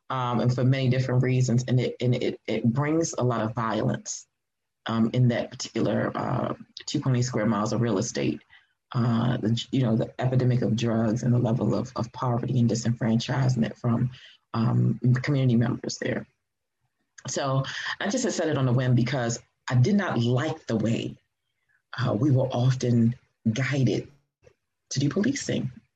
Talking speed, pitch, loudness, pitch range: 165 wpm, 125 Hz, -26 LUFS, 115-130 Hz